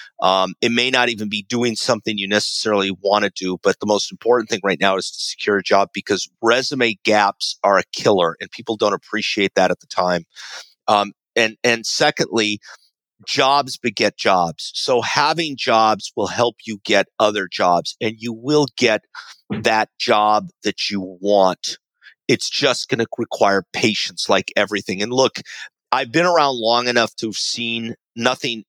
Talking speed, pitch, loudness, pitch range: 175 wpm, 115 Hz, -18 LUFS, 105-120 Hz